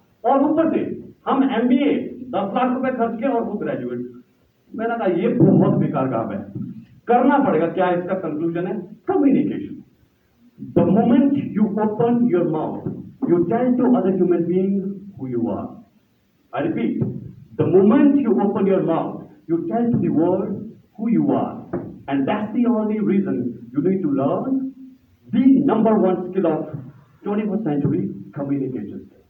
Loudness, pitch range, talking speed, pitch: -20 LUFS, 175-250 Hz, 145 wpm, 205 Hz